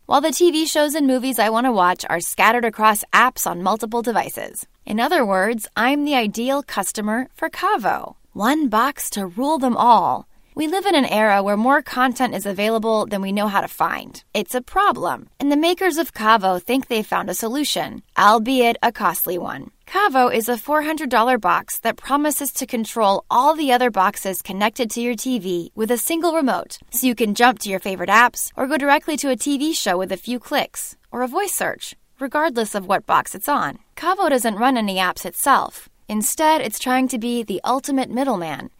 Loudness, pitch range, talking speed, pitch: -19 LUFS, 215-285 Hz, 200 wpm, 245 Hz